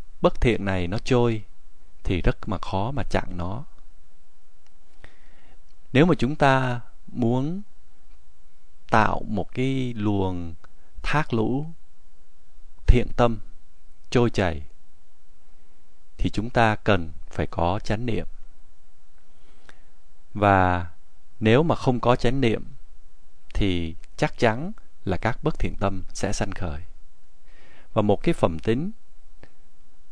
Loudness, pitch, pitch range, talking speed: -24 LUFS, 100 Hz, 80-120 Hz, 115 wpm